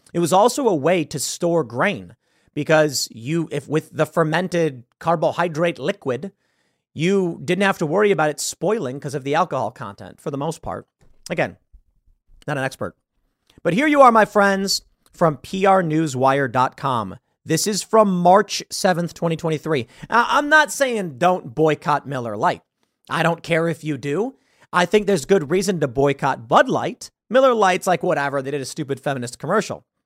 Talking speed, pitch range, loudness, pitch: 170 wpm, 145-190 Hz, -20 LUFS, 165 Hz